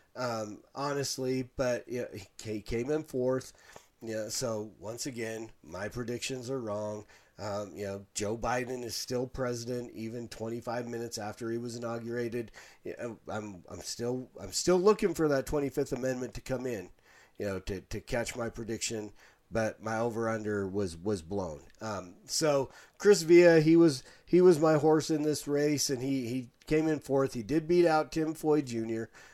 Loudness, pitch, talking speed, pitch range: -31 LUFS, 120 Hz, 180 wpm, 110-140 Hz